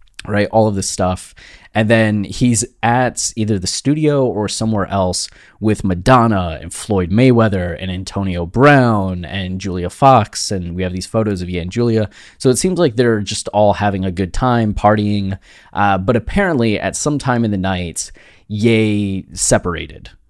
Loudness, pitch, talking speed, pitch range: -16 LUFS, 105 Hz, 170 wpm, 95-115 Hz